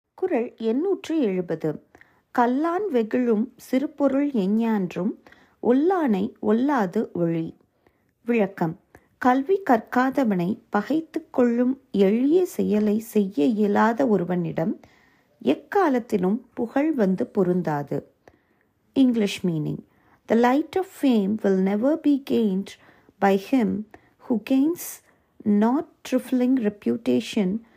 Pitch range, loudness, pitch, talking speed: 200-270 Hz, -23 LUFS, 230 Hz, 90 wpm